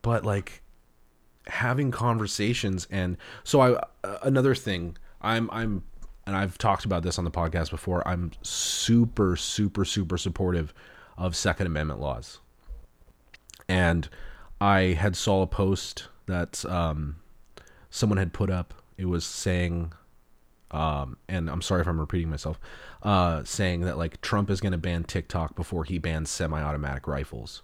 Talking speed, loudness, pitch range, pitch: 145 wpm, -28 LUFS, 80-100 Hz, 90 Hz